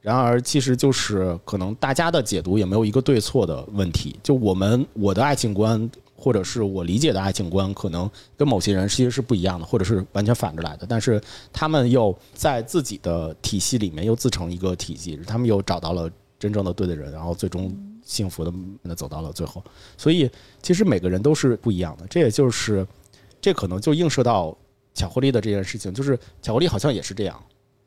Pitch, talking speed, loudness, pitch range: 100 Hz, 325 characters per minute, -22 LUFS, 95-125 Hz